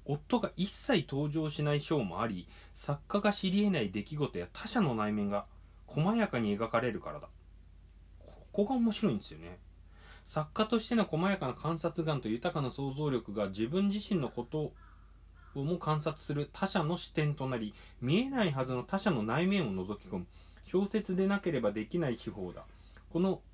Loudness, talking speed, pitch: -34 LUFS, 325 characters per minute, 145 Hz